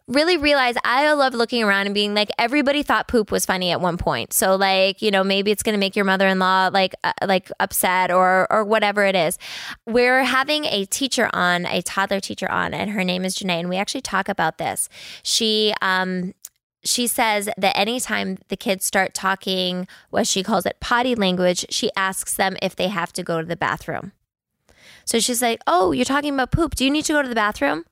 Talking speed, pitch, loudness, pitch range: 215 wpm, 200 Hz, -20 LUFS, 190-240 Hz